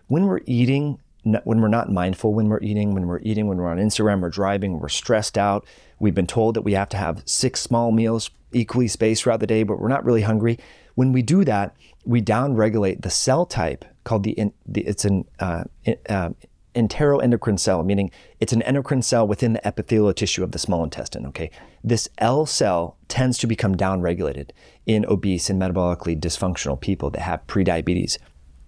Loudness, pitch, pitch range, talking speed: -22 LUFS, 105 Hz, 95-115 Hz, 185 wpm